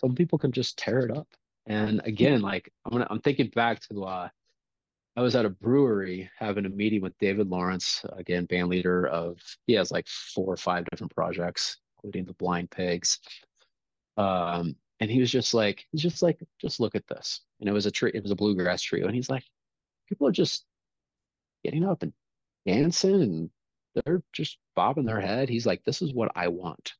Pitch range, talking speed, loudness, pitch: 90-125 Hz, 200 wpm, -28 LUFS, 105 Hz